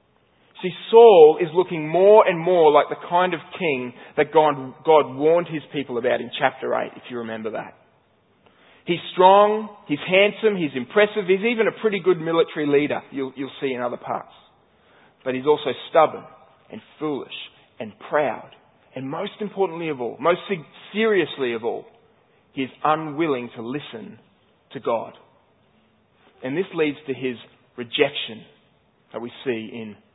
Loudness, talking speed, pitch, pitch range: -21 LUFS, 155 wpm, 160 Hz, 135-185 Hz